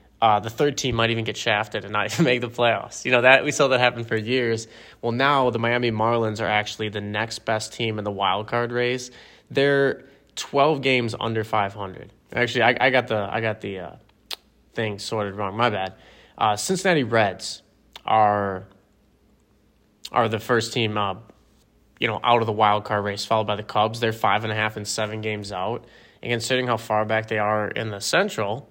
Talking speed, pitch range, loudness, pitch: 205 wpm, 105-120 Hz, -22 LUFS, 110 Hz